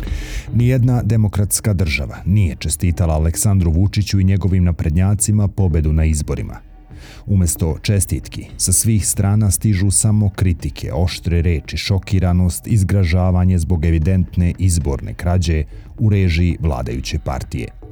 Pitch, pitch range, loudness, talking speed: 95 Hz, 85-105 Hz, -17 LUFS, 110 wpm